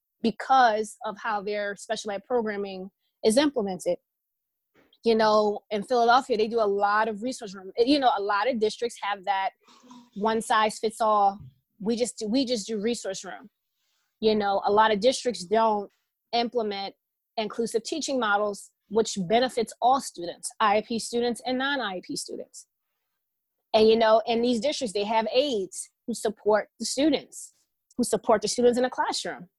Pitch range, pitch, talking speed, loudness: 210-245 Hz, 225 Hz, 160 wpm, -26 LUFS